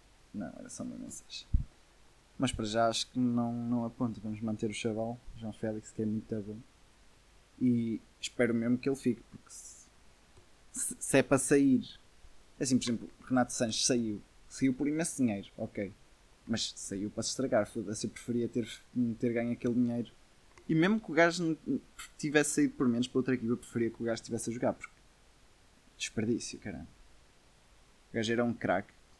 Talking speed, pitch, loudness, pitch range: 180 wpm, 120 Hz, -33 LUFS, 110-125 Hz